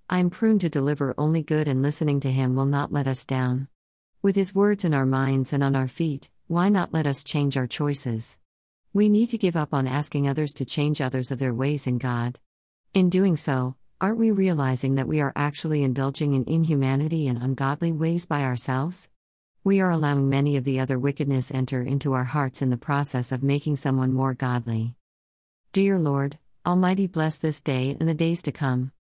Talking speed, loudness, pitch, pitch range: 200 wpm, -24 LUFS, 140 Hz, 130-160 Hz